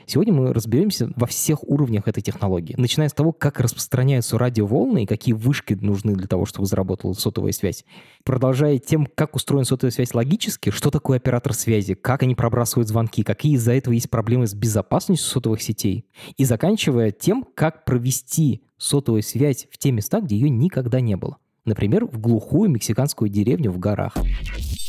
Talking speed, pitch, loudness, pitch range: 170 wpm, 120 Hz, -21 LUFS, 110-140 Hz